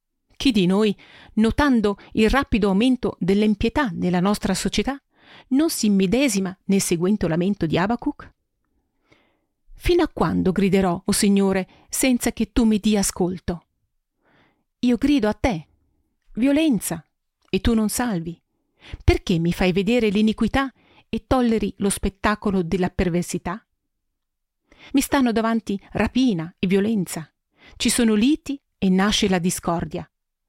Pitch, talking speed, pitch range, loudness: 205 Hz, 130 wpm, 185-240 Hz, -21 LUFS